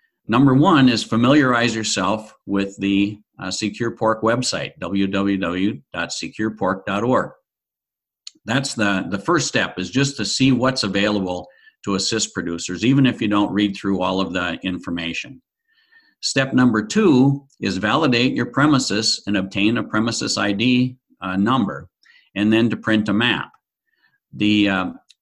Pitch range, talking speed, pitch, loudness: 100-125 Hz, 140 wpm, 110 Hz, -19 LUFS